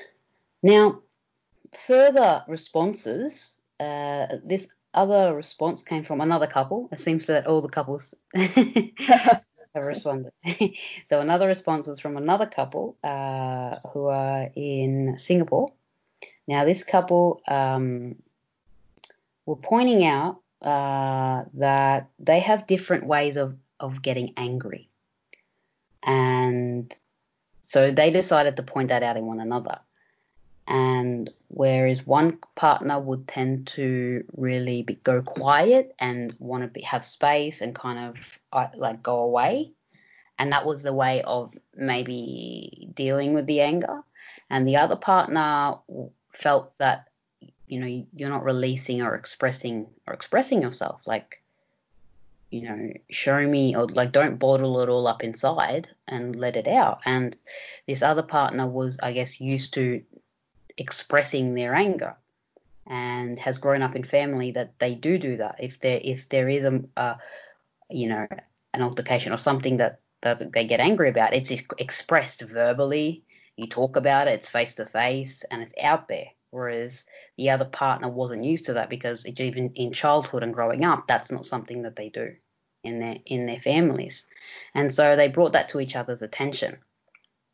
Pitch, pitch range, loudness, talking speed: 135 Hz, 125-155 Hz, -24 LUFS, 150 wpm